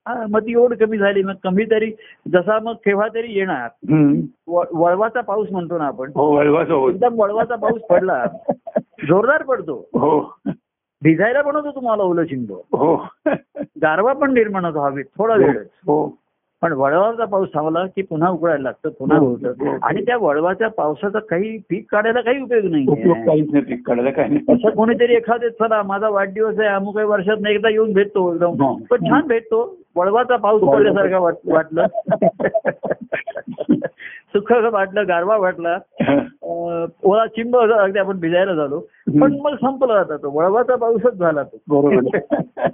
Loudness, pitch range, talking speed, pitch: -18 LUFS, 170-230 Hz, 135 wpm, 205 Hz